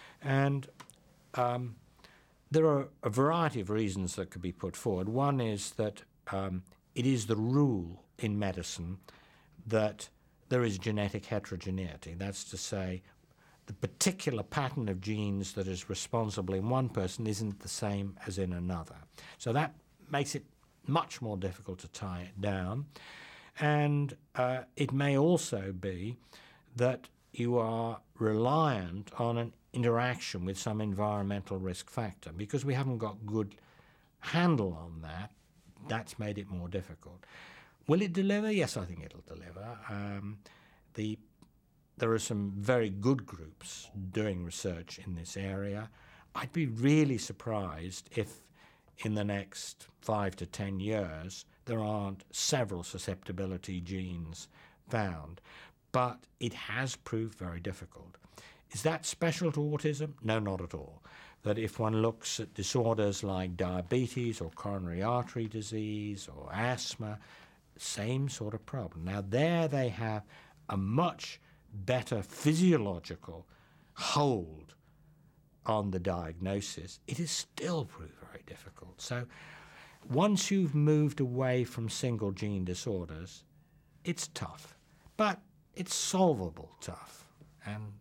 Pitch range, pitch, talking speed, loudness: 95-135 Hz, 110 Hz, 135 wpm, -34 LUFS